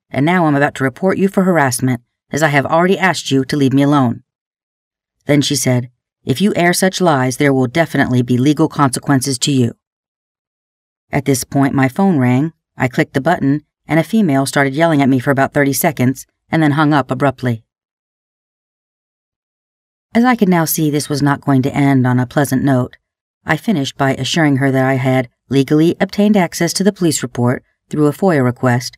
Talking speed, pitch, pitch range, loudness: 195 wpm, 140 Hz, 130-160 Hz, -14 LUFS